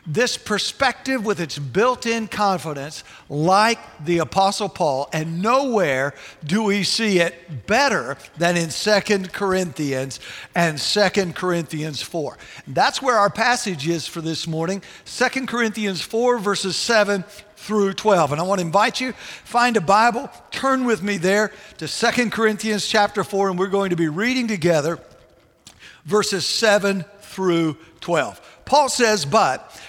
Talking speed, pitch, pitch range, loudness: 145 wpm, 200 Hz, 170-215 Hz, -20 LUFS